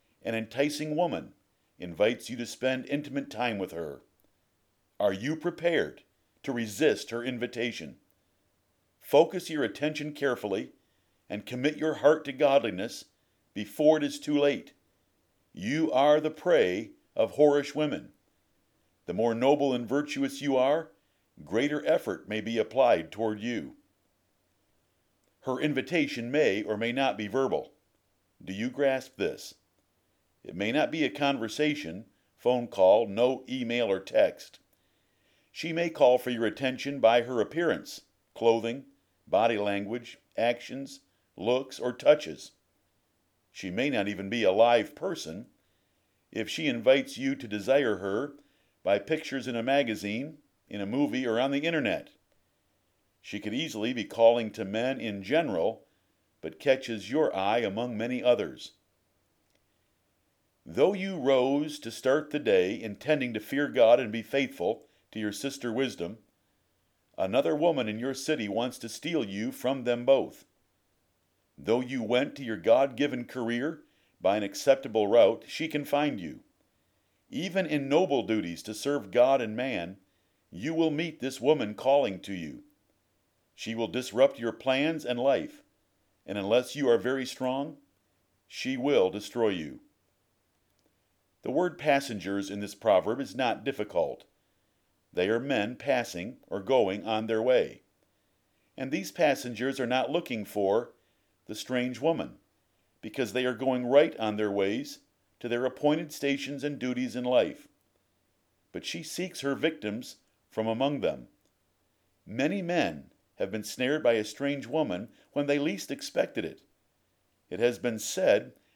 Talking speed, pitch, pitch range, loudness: 145 wpm, 125 Hz, 110-145 Hz, -29 LUFS